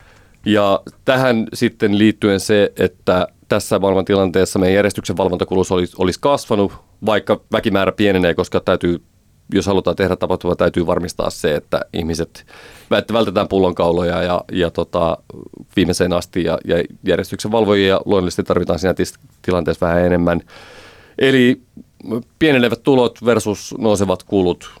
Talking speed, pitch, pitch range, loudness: 125 wpm, 100 Hz, 90-110 Hz, -17 LUFS